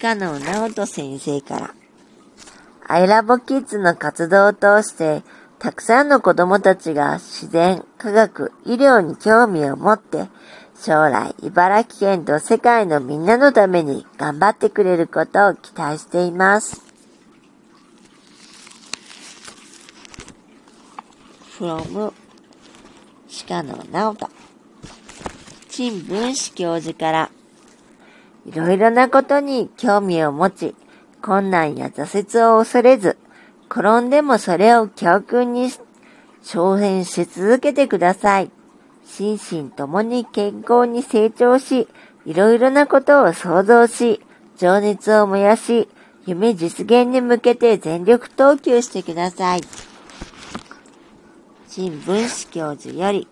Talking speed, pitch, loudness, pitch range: 210 characters per minute, 210 Hz, -17 LUFS, 175-240 Hz